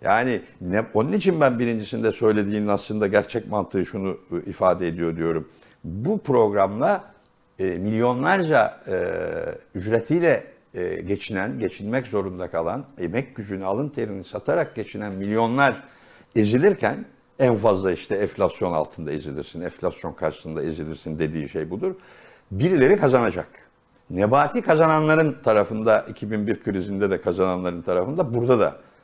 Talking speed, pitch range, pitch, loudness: 120 wpm, 95-140 Hz, 110 Hz, -23 LUFS